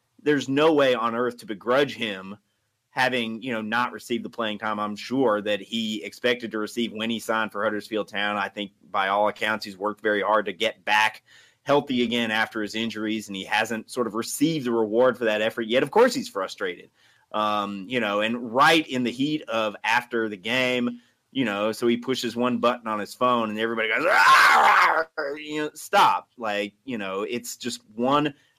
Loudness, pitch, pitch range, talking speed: -24 LUFS, 115 Hz, 105-125 Hz, 205 wpm